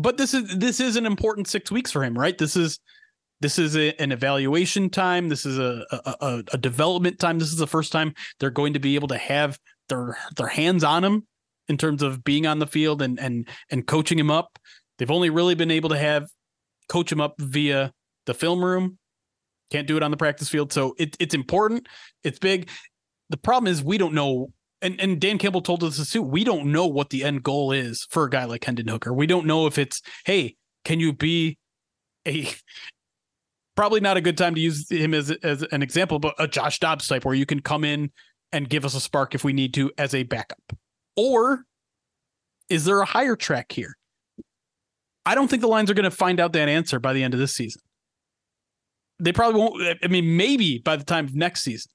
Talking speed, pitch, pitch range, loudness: 225 wpm, 155 Hz, 140-175 Hz, -23 LUFS